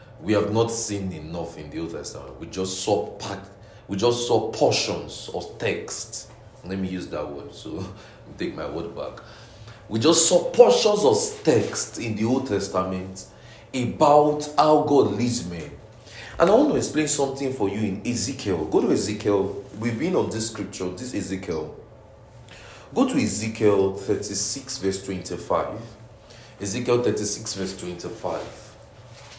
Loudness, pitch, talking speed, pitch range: -23 LUFS, 110 Hz, 155 wpm, 100-120 Hz